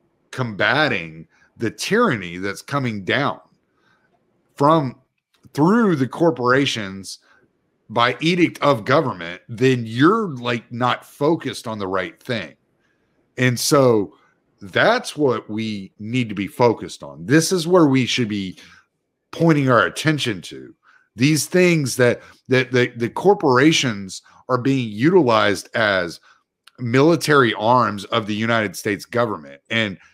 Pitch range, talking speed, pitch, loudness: 110-145 Hz, 125 wpm, 125 Hz, -19 LUFS